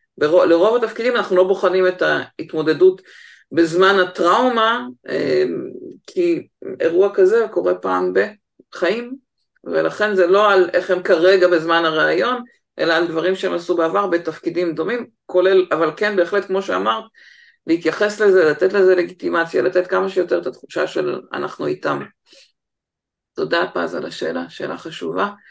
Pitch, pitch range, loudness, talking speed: 185 Hz, 175-230 Hz, -18 LUFS, 135 wpm